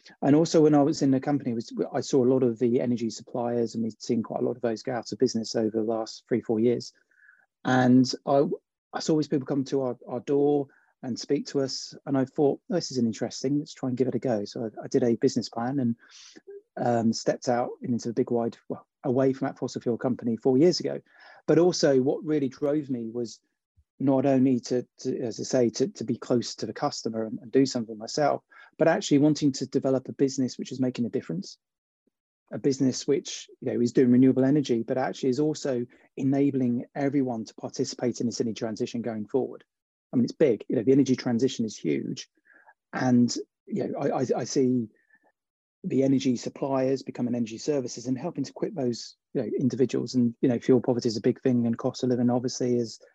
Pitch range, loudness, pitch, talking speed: 120-140 Hz, -27 LUFS, 130 Hz, 220 wpm